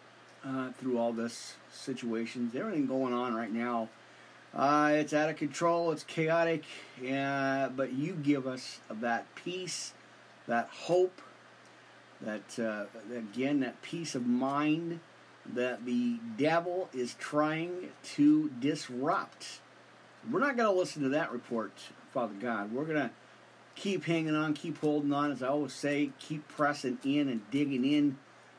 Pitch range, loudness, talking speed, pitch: 125-155 Hz, -33 LUFS, 145 wpm, 140 Hz